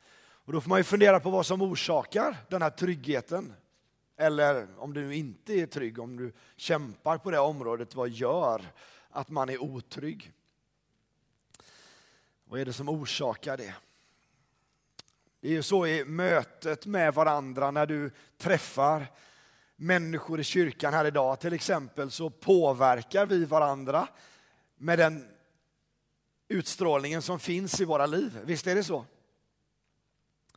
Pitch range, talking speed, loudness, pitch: 135-175 Hz, 140 wpm, -29 LUFS, 155 Hz